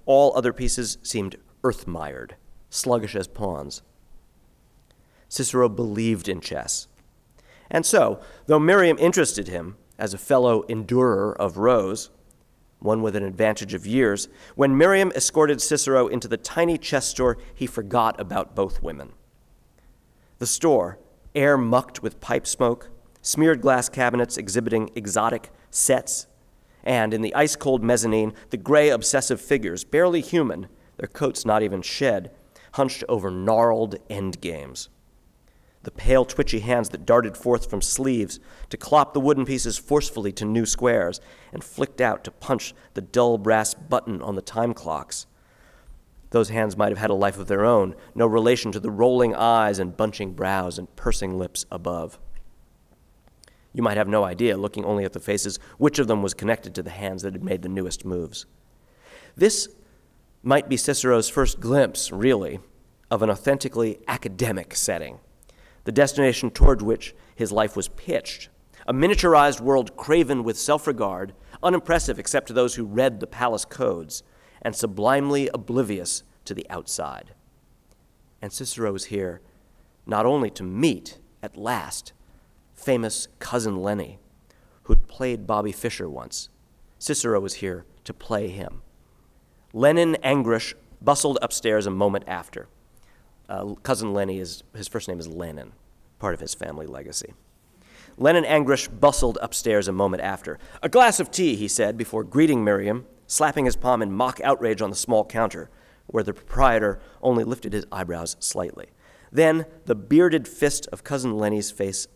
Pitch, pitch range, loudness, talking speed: 115 Hz, 100-130 Hz, -23 LUFS, 155 wpm